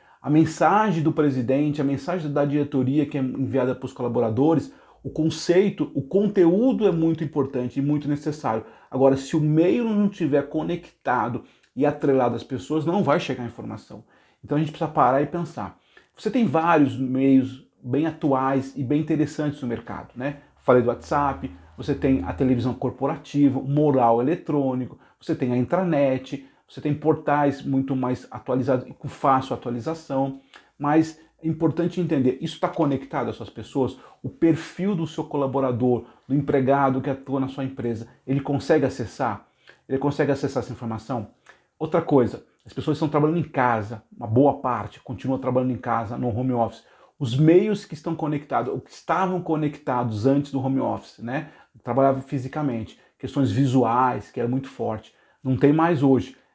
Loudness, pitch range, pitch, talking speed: -23 LUFS, 130-155 Hz, 140 Hz, 165 wpm